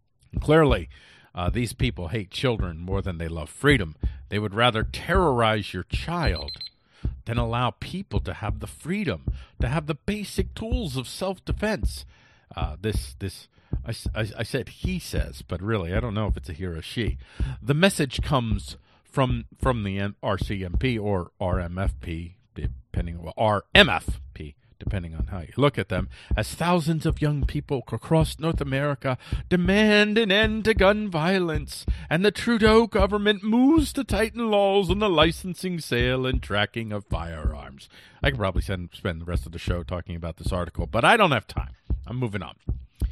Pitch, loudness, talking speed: 110 Hz, -25 LUFS, 170 wpm